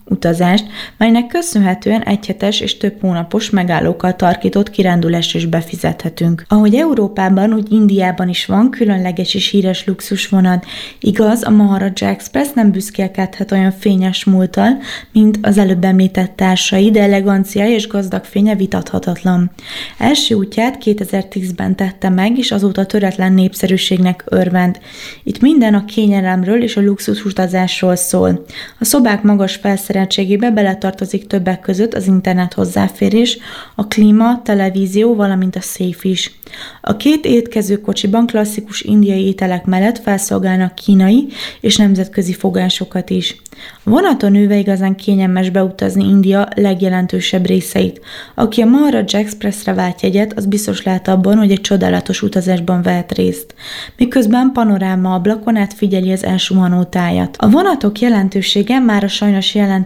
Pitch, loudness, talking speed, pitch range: 195 Hz, -13 LUFS, 130 wpm, 185-215 Hz